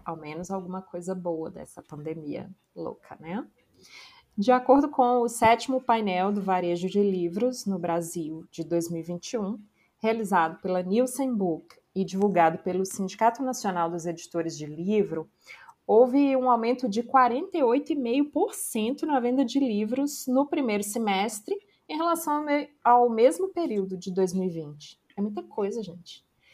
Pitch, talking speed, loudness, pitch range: 205 Hz, 135 wpm, -26 LUFS, 175-255 Hz